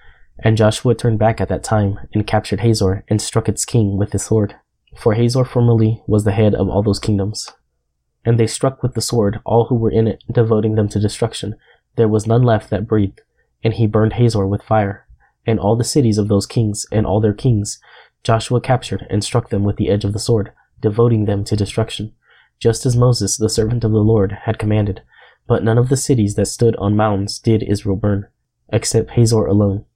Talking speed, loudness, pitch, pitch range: 210 wpm, -17 LUFS, 110 Hz, 100-115 Hz